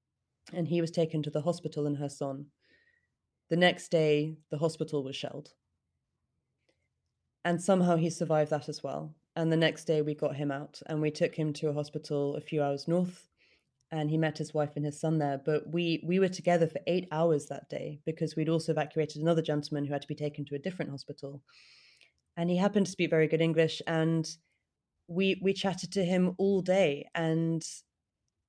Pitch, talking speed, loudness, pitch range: 155 Hz, 200 wpm, -31 LUFS, 145-170 Hz